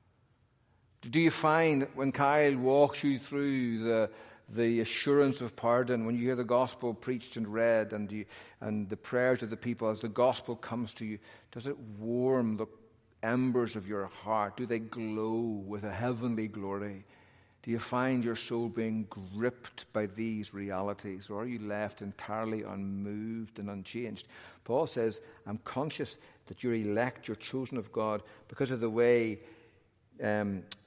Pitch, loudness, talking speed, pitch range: 115 Hz, -33 LUFS, 165 wpm, 105-125 Hz